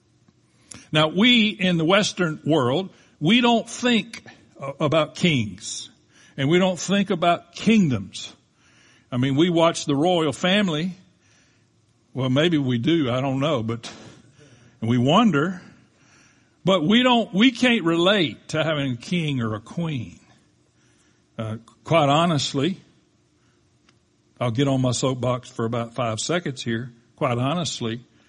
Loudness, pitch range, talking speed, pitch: -21 LUFS, 120-175 Hz, 130 wpm, 145 Hz